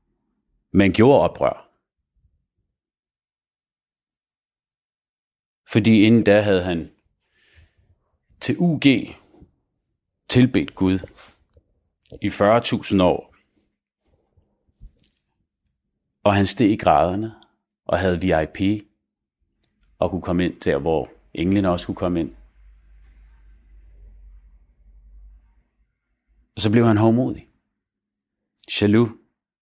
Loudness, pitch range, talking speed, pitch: -19 LUFS, 75-105 Hz, 80 wpm, 90 Hz